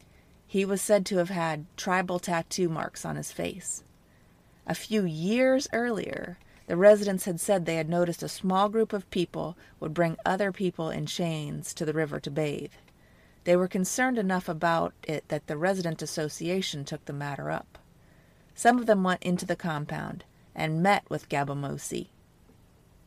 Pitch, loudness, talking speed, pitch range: 175 Hz, -28 LUFS, 165 wpm, 160-195 Hz